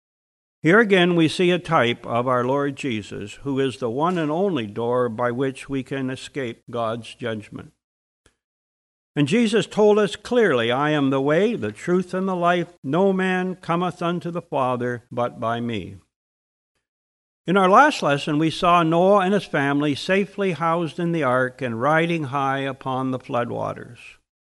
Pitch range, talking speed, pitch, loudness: 125-175 Hz, 170 wpm, 140 Hz, -21 LUFS